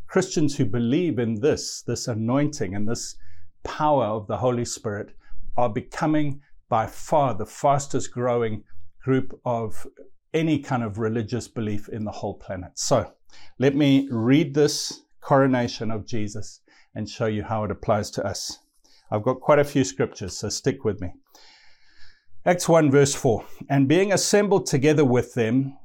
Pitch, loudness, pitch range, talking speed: 125 Hz, -23 LUFS, 110-145 Hz, 160 wpm